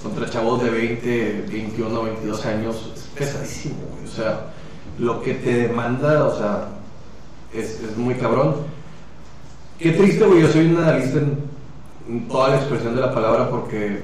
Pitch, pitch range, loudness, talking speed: 120 Hz, 115-140 Hz, -20 LUFS, 160 wpm